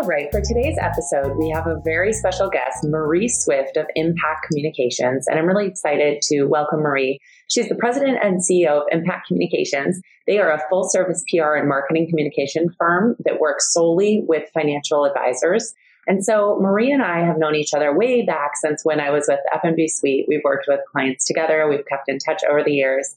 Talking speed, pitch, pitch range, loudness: 195 wpm, 155 Hz, 145-180 Hz, -19 LUFS